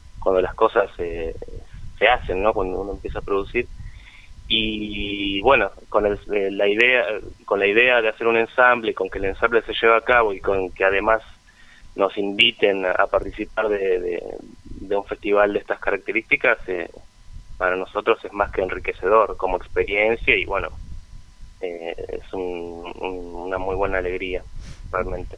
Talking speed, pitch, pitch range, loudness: 165 wpm, 100 Hz, 95-115 Hz, -21 LUFS